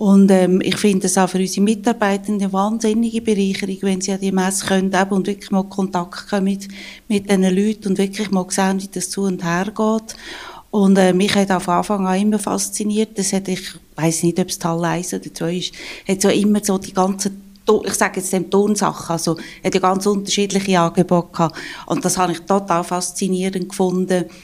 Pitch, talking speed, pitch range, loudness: 195 Hz, 195 wpm, 180-200 Hz, -18 LUFS